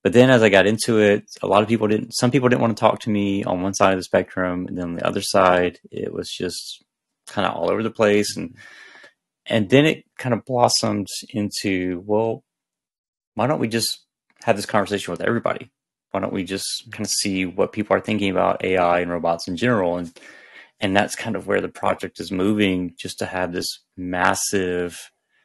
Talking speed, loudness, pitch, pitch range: 215 wpm, -21 LUFS, 100 Hz, 90-110 Hz